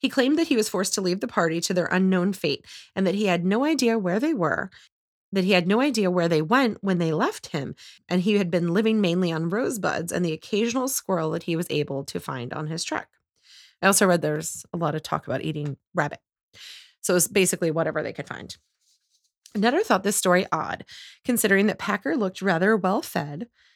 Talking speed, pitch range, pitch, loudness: 220 wpm, 170-215 Hz, 185 Hz, -24 LUFS